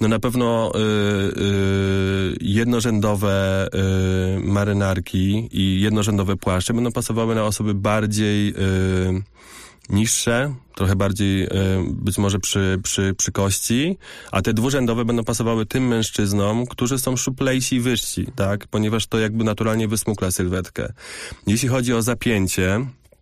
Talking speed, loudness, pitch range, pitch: 130 wpm, -20 LUFS, 95-115 Hz, 105 Hz